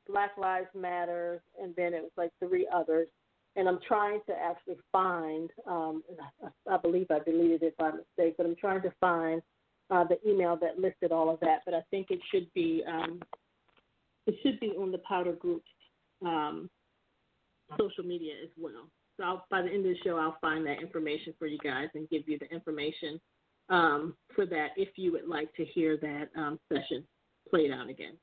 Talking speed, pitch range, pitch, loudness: 195 wpm, 160-185 Hz, 170 Hz, -32 LUFS